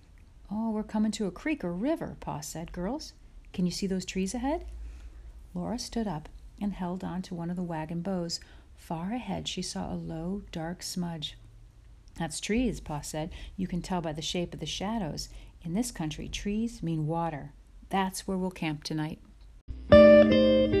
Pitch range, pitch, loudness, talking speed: 155-195 Hz, 175 Hz, -29 LUFS, 175 wpm